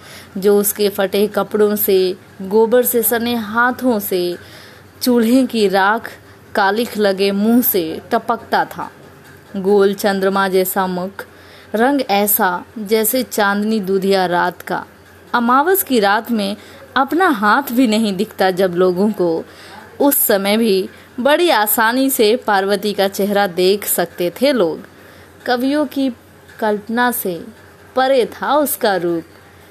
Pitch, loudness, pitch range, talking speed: 210 Hz, -16 LUFS, 195-240 Hz, 125 wpm